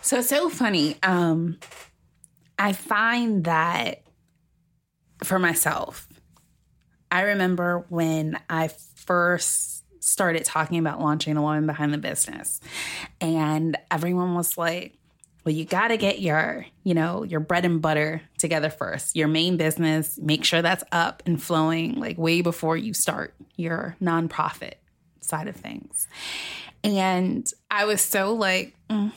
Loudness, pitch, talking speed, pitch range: -24 LUFS, 170 Hz, 135 wpm, 160-190 Hz